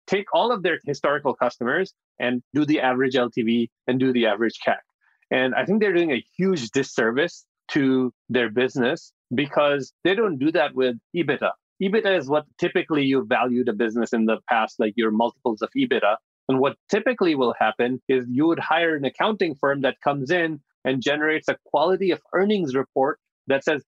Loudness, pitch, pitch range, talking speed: -23 LUFS, 135 Hz, 125-165 Hz, 185 wpm